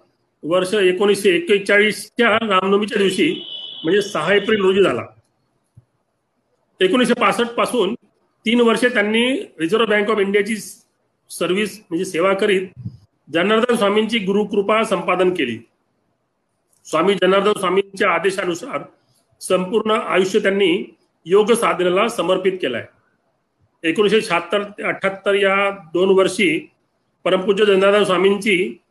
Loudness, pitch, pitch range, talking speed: -17 LUFS, 200 Hz, 185-215 Hz, 100 wpm